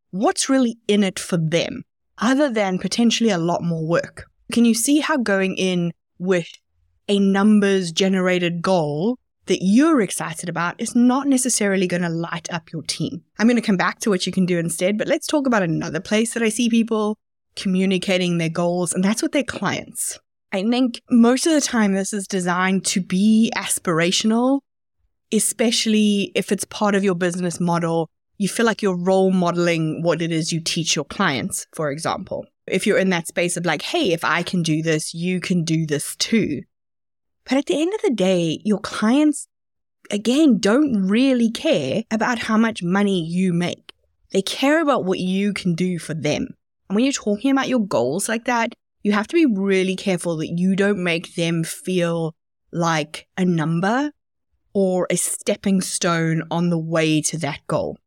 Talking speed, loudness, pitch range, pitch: 185 wpm, -20 LUFS, 175-225 Hz, 190 Hz